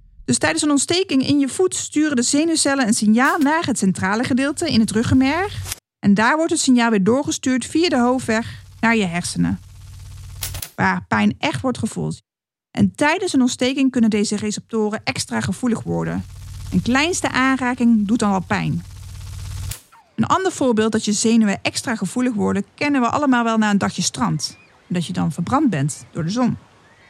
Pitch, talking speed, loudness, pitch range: 225 Hz, 175 wpm, -19 LUFS, 180-265 Hz